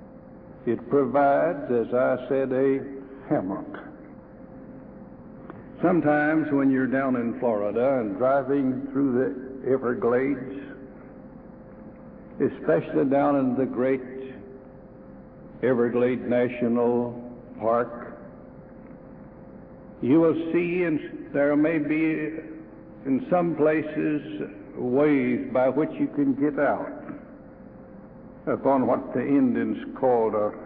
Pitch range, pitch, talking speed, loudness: 125-155 Hz, 135 Hz, 95 wpm, -24 LUFS